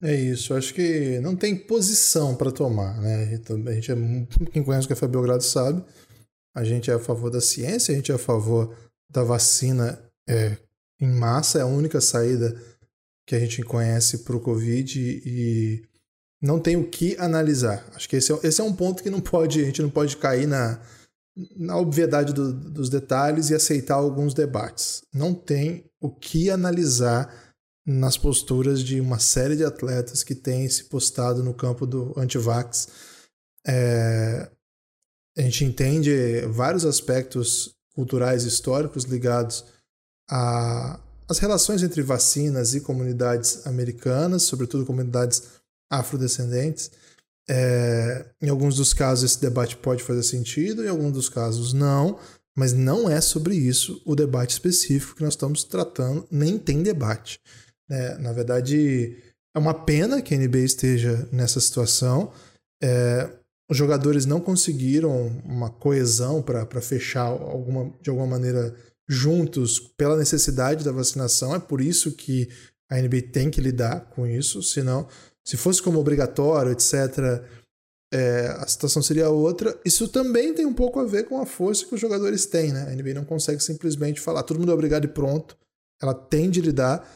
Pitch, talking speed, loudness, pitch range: 130 Hz, 160 wpm, -23 LUFS, 120-155 Hz